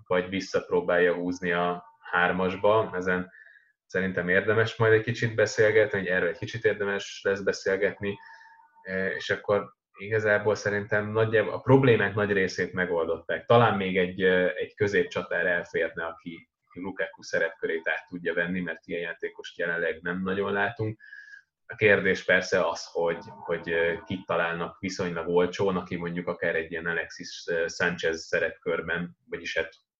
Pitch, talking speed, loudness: 110 Hz, 140 wpm, -27 LUFS